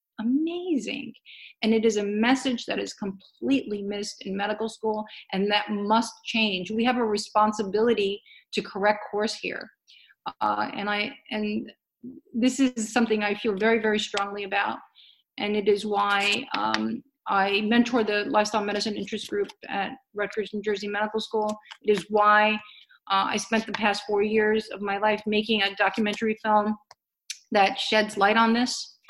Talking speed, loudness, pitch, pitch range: 160 wpm, -25 LUFS, 215 Hz, 205-230 Hz